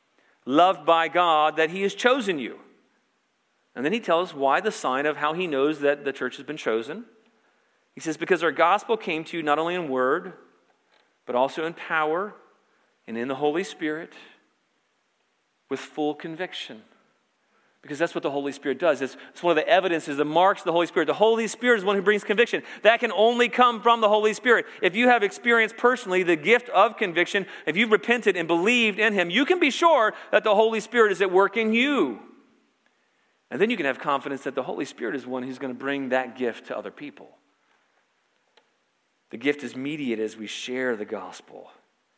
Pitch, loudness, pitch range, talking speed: 175 Hz, -23 LUFS, 145-220 Hz, 205 wpm